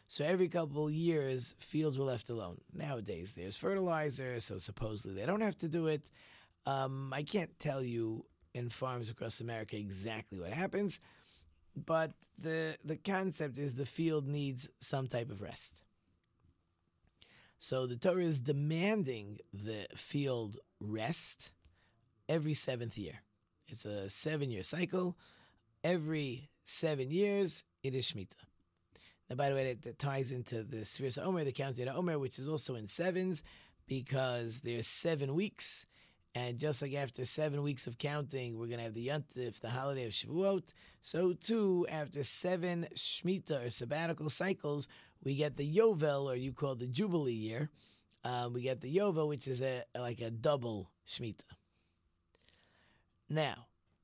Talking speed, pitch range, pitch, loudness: 155 wpm, 115-155 Hz, 130 Hz, -37 LUFS